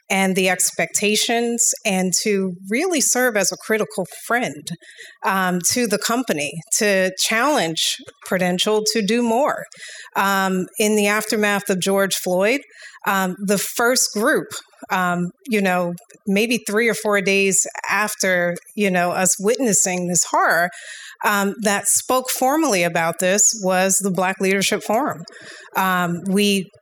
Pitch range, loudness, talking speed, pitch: 185-220 Hz, -19 LUFS, 135 wpm, 200 Hz